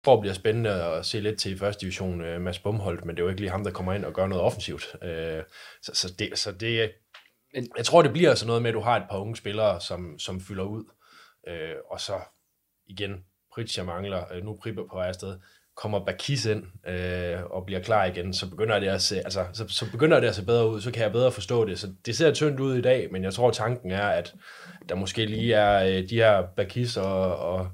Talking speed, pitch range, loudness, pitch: 255 wpm, 95-115 Hz, -26 LUFS, 100 Hz